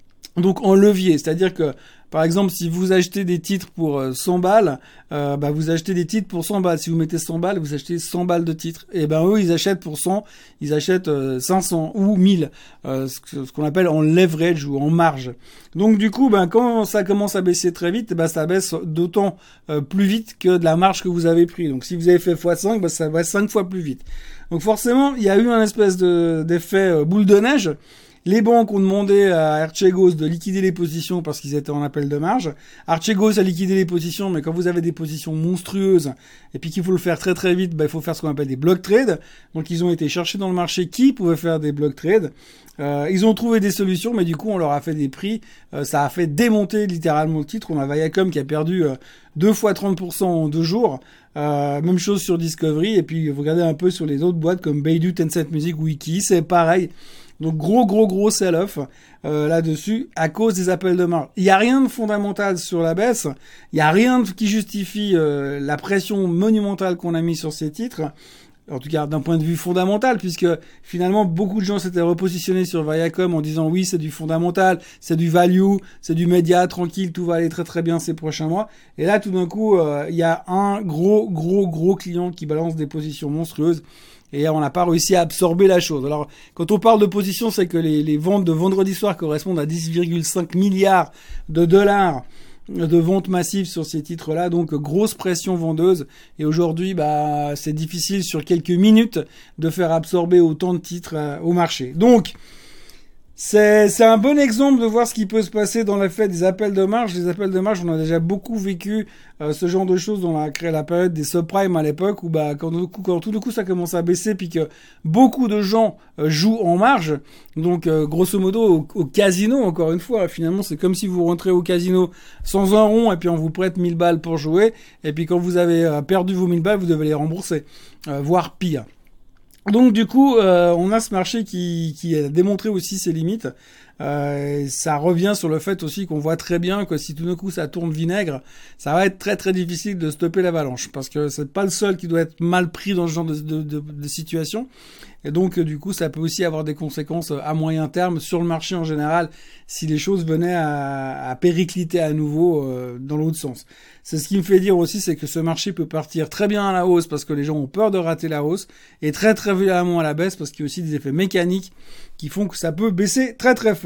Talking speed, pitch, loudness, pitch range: 235 wpm, 175 Hz, -19 LUFS, 160-195 Hz